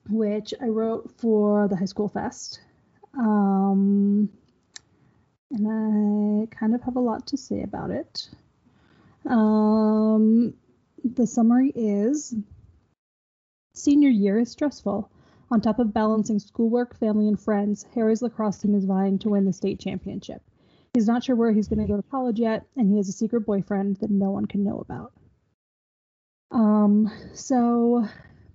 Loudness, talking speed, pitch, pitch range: -23 LUFS, 150 wpm, 215 Hz, 205-235 Hz